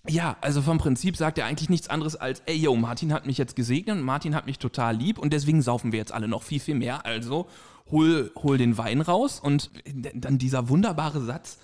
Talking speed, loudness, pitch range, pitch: 225 wpm, -26 LUFS, 125-155 Hz, 145 Hz